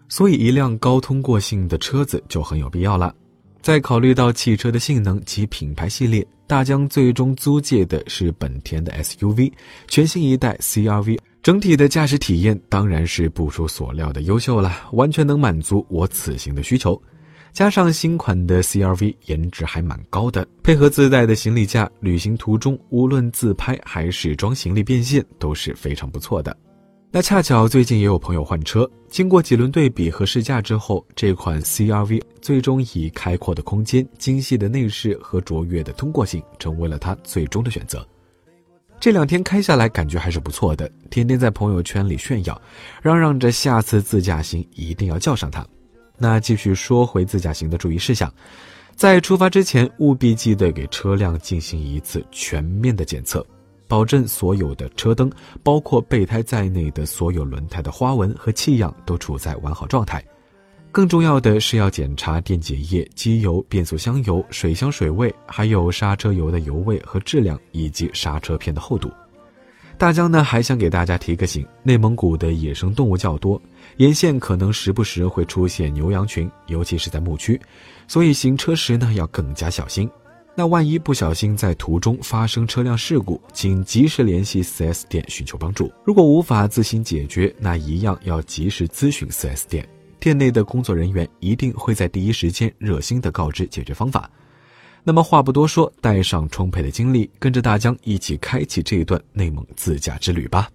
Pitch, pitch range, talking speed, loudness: 100 Hz, 85-125 Hz, 280 characters per minute, -19 LUFS